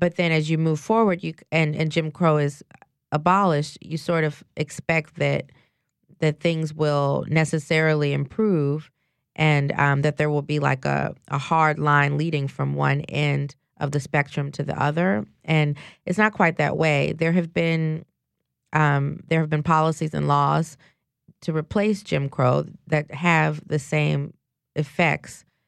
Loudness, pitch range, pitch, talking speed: -23 LUFS, 145-165 Hz, 155 Hz, 160 wpm